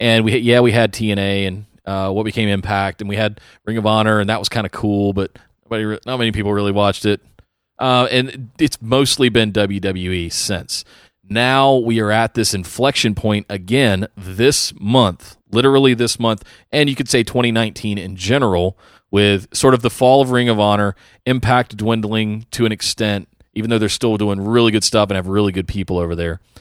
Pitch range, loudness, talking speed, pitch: 100-120 Hz, -17 LUFS, 195 wpm, 110 Hz